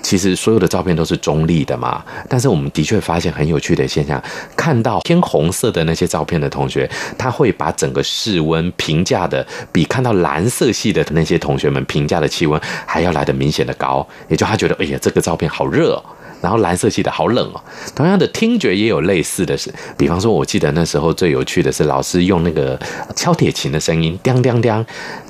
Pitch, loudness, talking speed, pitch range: 85 Hz, -16 LUFS, 325 characters per minute, 80-110 Hz